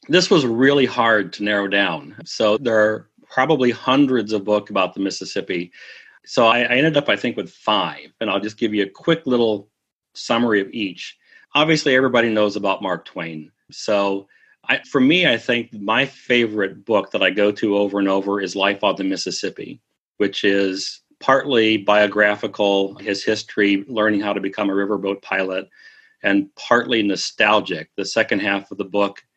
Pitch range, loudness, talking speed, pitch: 100-120 Hz, -19 LUFS, 175 wpm, 105 Hz